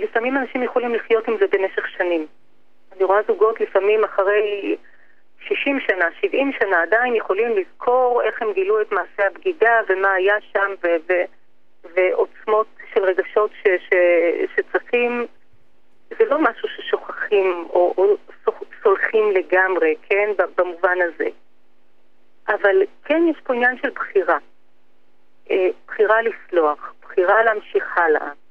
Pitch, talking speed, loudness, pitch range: 215 Hz, 130 wpm, -19 LUFS, 190-310 Hz